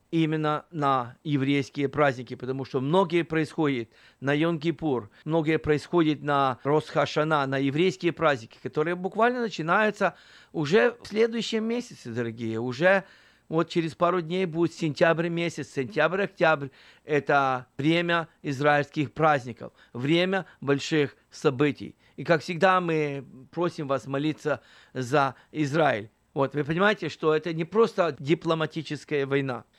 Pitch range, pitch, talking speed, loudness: 140-170 Hz, 155 Hz, 120 wpm, -26 LUFS